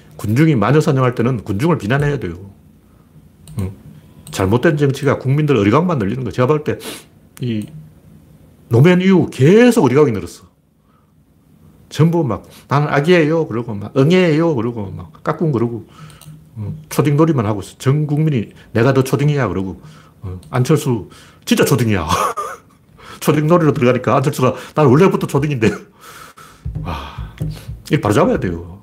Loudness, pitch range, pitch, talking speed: -15 LUFS, 100-155 Hz, 130 Hz, 310 characters per minute